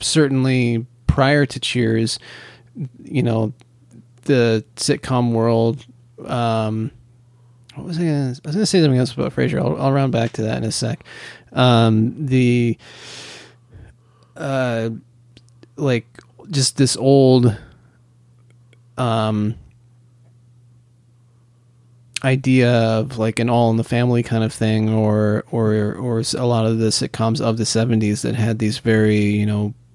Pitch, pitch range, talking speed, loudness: 120 Hz, 115-125 Hz, 130 wpm, -18 LUFS